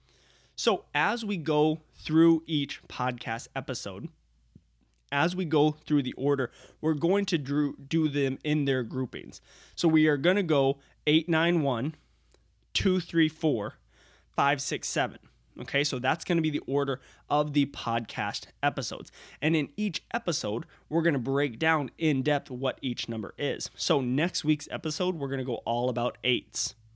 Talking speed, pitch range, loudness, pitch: 155 wpm, 130-160 Hz, -28 LUFS, 145 Hz